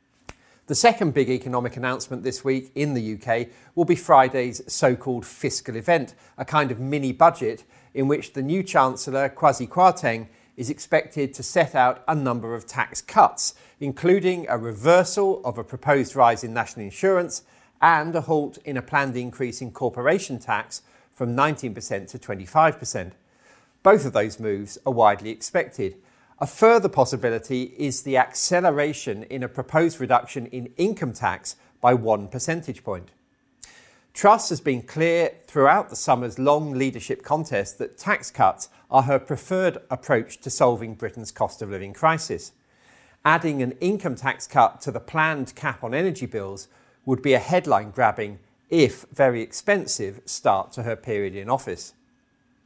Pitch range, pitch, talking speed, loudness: 120-155 Hz, 130 Hz, 155 wpm, -23 LUFS